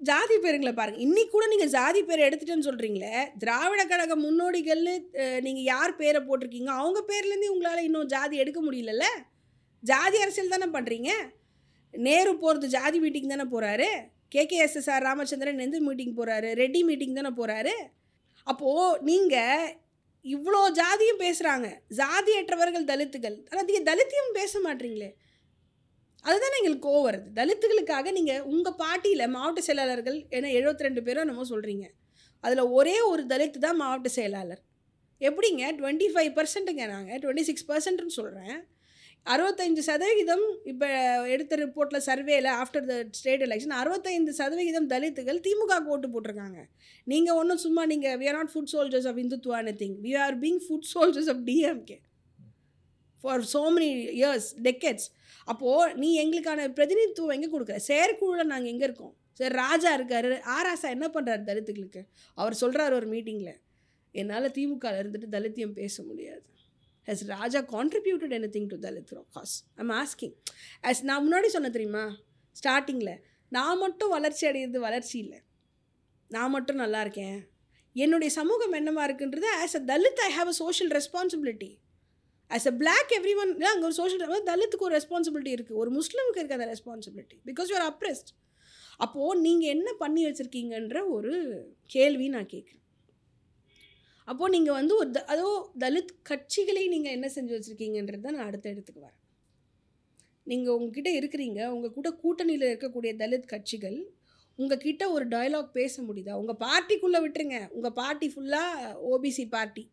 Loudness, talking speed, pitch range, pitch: -28 LUFS, 145 wpm, 240-335 Hz, 280 Hz